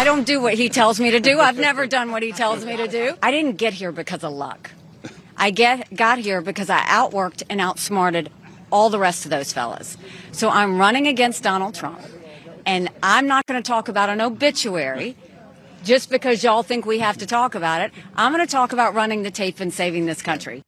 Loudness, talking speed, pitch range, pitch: -19 LUFS, 225 wpm, 180-240 Hz, 210 Hz